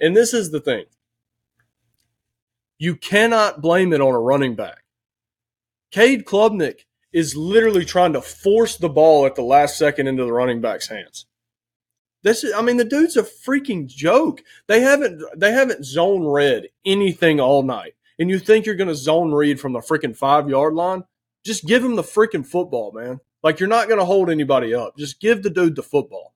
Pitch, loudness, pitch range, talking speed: 160 Hz, -18 LUFS, 130-210 Hz, 190 wpm